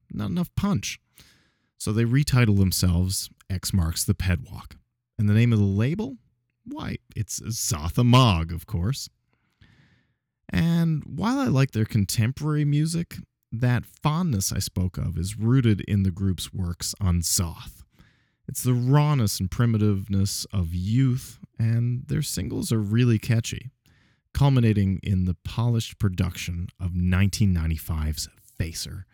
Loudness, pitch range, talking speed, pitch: -24 LUFS, 95-125 Hz, 130 wpm, 110 Hz